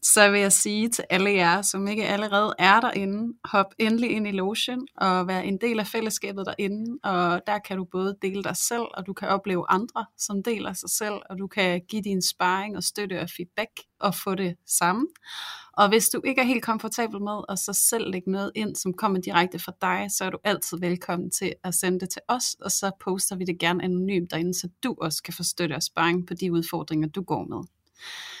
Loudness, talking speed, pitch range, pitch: -25 LUFS, 225 wpm, 180-215 Hz, 195 Hz